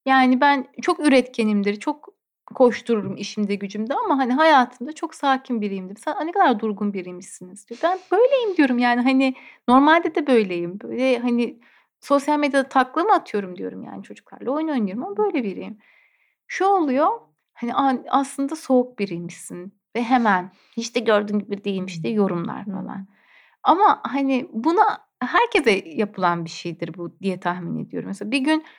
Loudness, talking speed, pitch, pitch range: -21 LUFS, 150 wpm, 250 Hz, 205-295 Hz